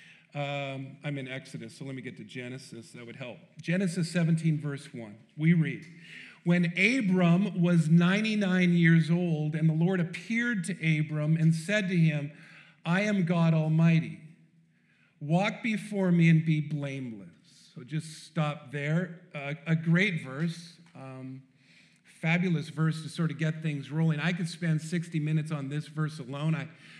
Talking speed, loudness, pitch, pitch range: 160 wpm, -28 LUFS, 160 Hz, 150-175 Hz